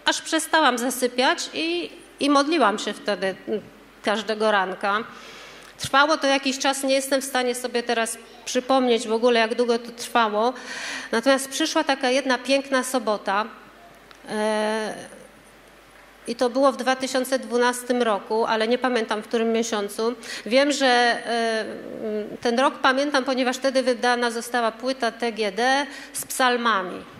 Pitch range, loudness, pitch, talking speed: 225-270 Hz, -23 LUFS, 245 Hz, 130 wpm